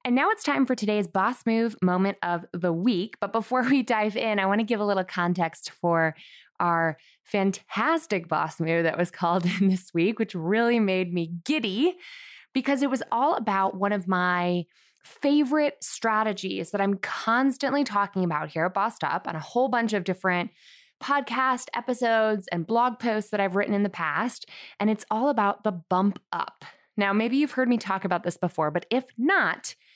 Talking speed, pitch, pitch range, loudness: 190 wpm, 205 Hz, 180-245 Hz, -25 LUFS